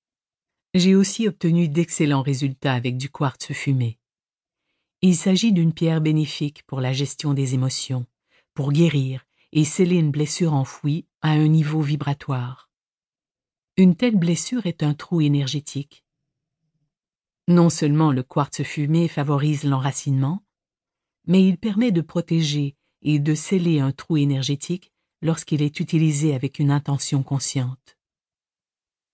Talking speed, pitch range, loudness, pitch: 130 wpm, 140-170 Hz, -21 LUFS, 150 Hz